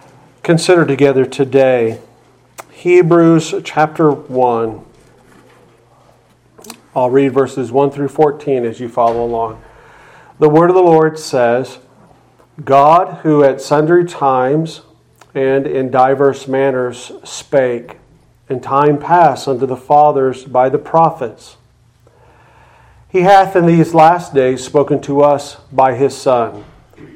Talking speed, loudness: 115 wpm, -12 LUFS